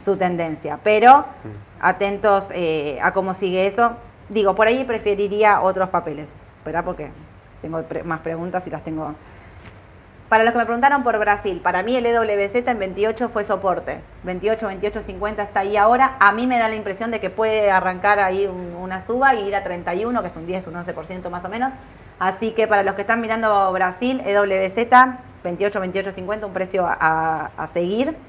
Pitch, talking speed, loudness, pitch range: 195 Hz, 190 wpm, -20 LUFS, 175-220 Hz